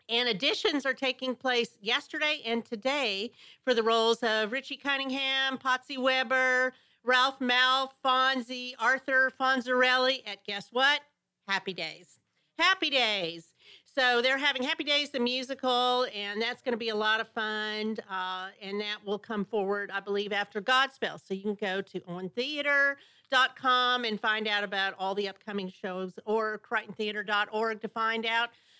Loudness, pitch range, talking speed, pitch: -28 LUFS, 210-260 Hz, 150 wpm, 235 Hz